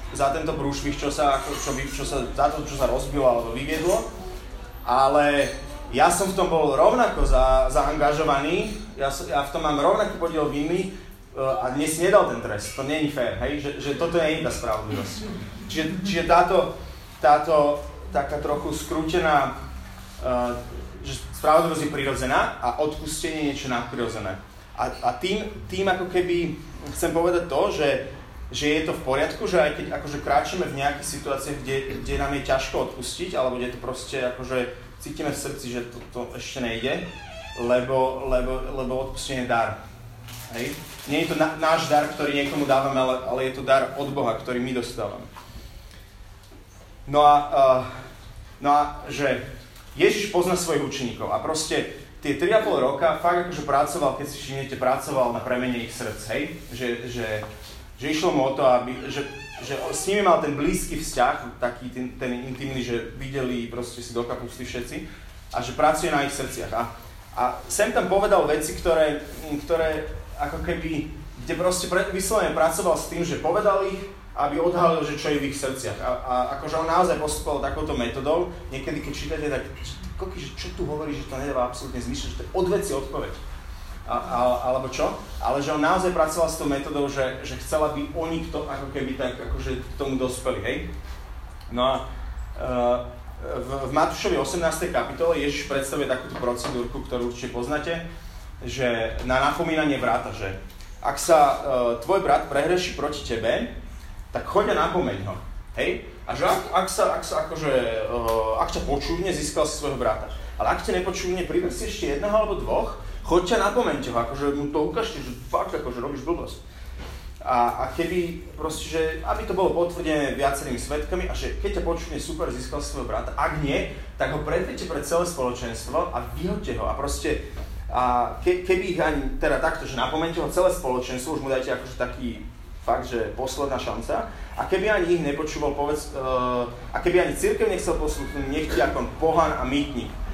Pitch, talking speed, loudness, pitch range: 140 Hz, 175 wpm, -25 LUFS, 125-160 Hz